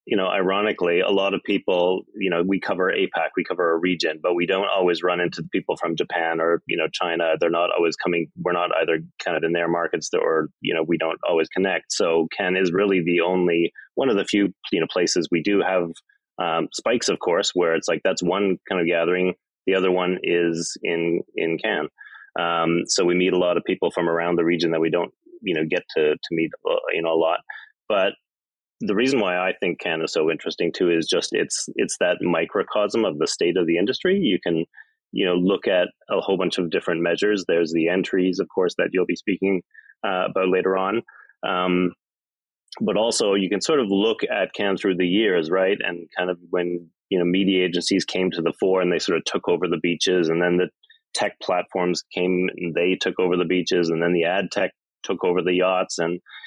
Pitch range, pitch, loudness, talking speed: 85-95 Hz, 90 Hz, -22 LUFS, 225 wpm